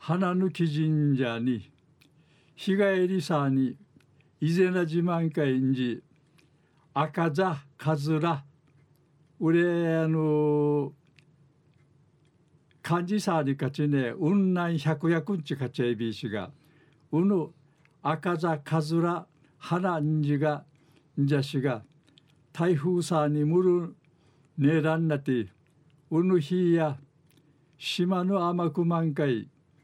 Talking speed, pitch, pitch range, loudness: 185 characters per minute, 155 Hz, 145-170 Hz, -27 LUFS